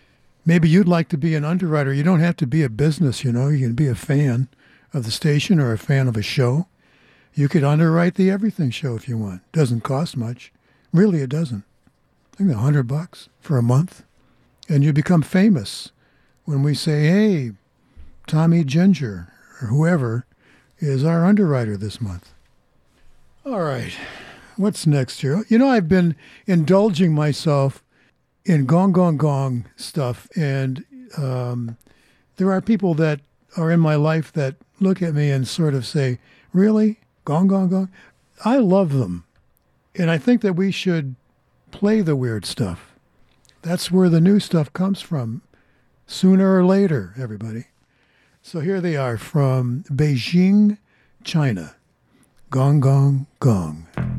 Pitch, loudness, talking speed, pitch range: 150 Hz, -19 LUFS, 155 wpm, 130-180 Hz